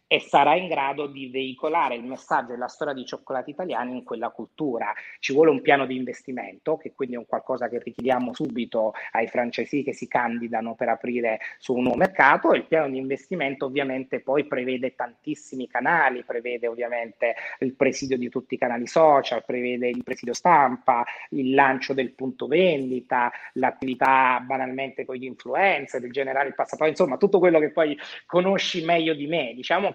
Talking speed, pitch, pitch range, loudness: 180 wpm, 130 Hz, 125-145 Hz, -24 LUFS